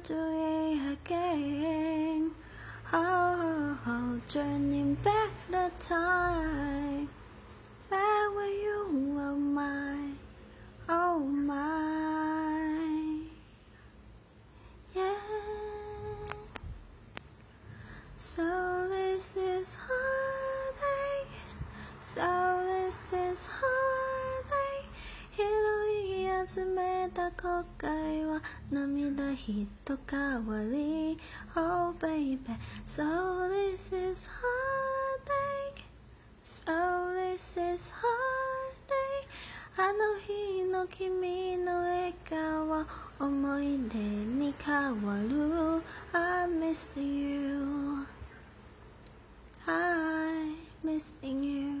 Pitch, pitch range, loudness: 315 Hz, 280-365 Hz, -33 LUFS